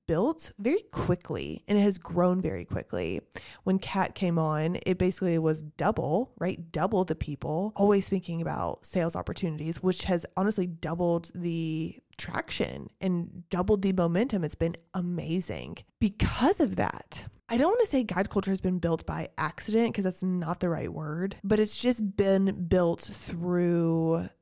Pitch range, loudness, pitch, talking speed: 170-195 Hz, -29 LUFS, 180 Hz, 160 wpm